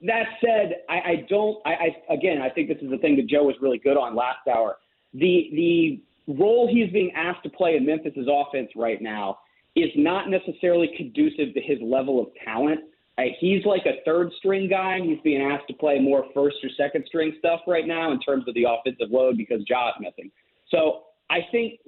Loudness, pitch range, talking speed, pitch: -23 LUFS, 140-195 Hz, 210 wpm, 160 Hz